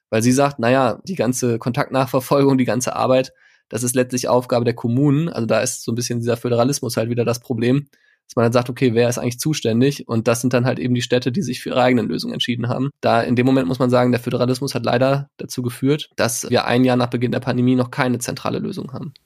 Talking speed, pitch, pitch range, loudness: 250 wpm, 125 Hz, 120-130 Hz, -19 LUFS